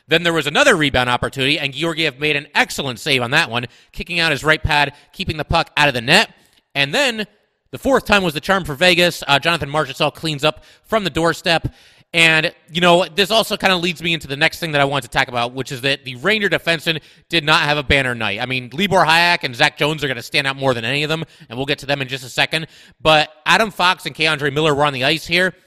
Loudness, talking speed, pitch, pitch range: -16 LUFS, 265 wpm, 155 Hz, 140-170 Hz